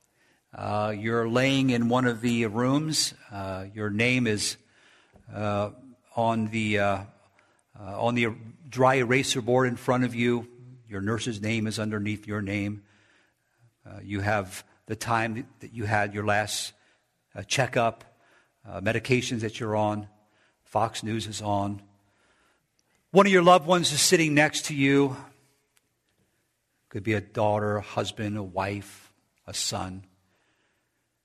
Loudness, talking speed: -26 LUFS, 140 wpm